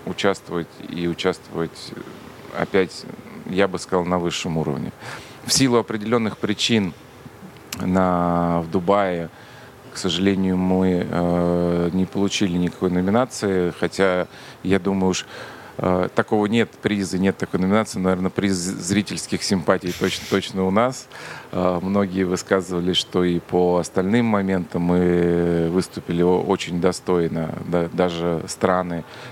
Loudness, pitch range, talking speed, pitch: -21 LUFS, 85-100 Hz, 120 wpm, 95 Hz